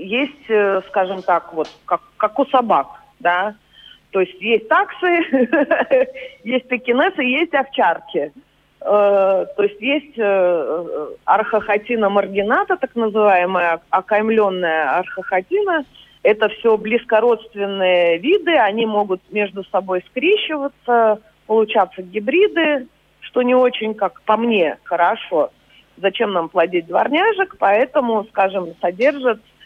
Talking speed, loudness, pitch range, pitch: 105 wpm, -18 LUFS, 195-280 Hz, 220 Hz